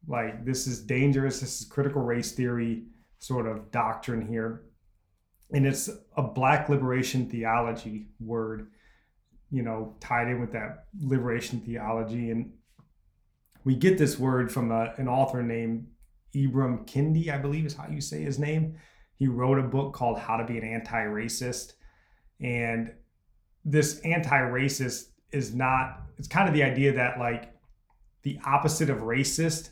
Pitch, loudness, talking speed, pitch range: 125 Hz, -28 LUFS, 155 wpm, 115-140 Hz